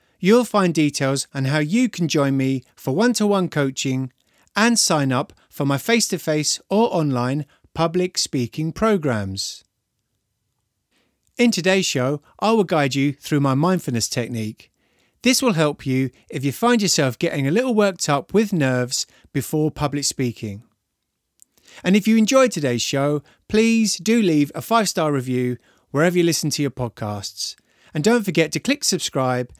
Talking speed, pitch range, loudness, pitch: 165 wpm, 130-190 Hz, -20 LUFS, 150 Hz